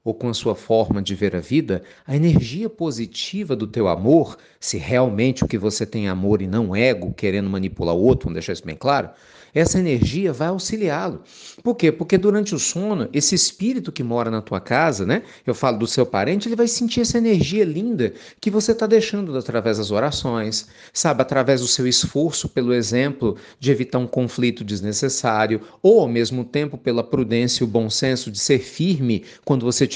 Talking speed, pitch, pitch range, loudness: 200 wpm, 130 Hz, 115-170 Hz, -20 LUFS